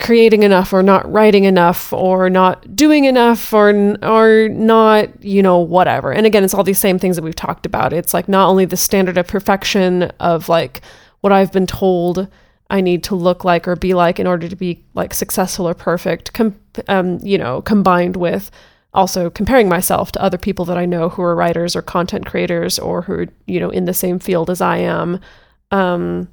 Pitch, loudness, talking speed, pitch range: 185 Hz, -14 LUFS, 205 wpm, 175-200 Hz